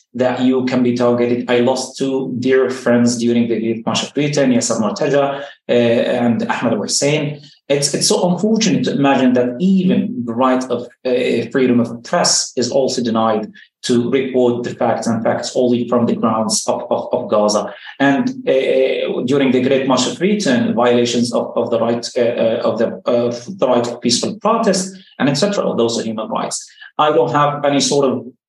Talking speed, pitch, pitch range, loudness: 190 wpm, 130 Hz, 120-145 Hz, -16 LUFS